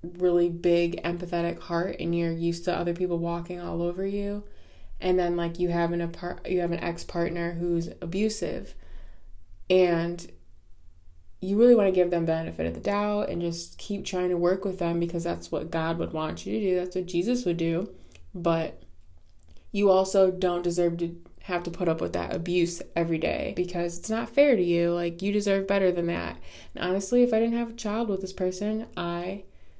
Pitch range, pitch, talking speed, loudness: 170-185 Hz, 175 Hz, 200 wpm, -27 LUFS